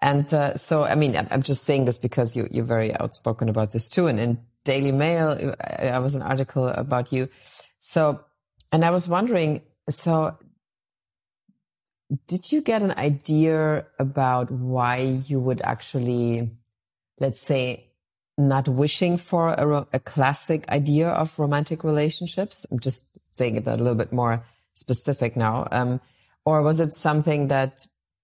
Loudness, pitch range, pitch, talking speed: -22 LUFS, 120-150 Hz, 135 Hz, 150 wpm